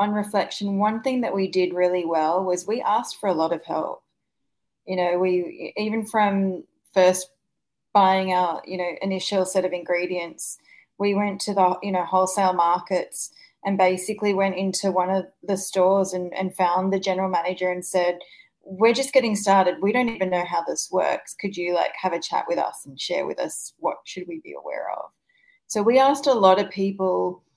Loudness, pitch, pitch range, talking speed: -23 LUFS, 190 Hz, 180-200 Hz, 200 wpm